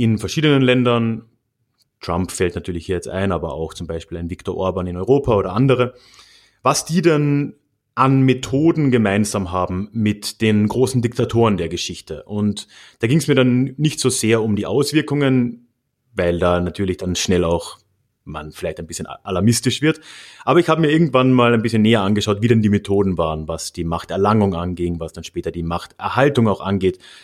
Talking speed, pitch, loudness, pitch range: 180 wpm, 110 Hz, -18 LUFS, 90-130 Hz